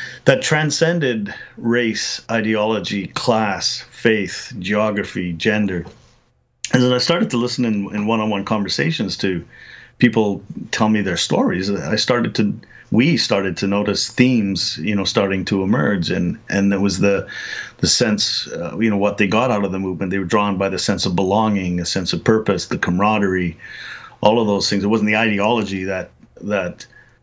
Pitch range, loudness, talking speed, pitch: 95-110 Hz, -18 LUFS, 170 wpm, 105 Hz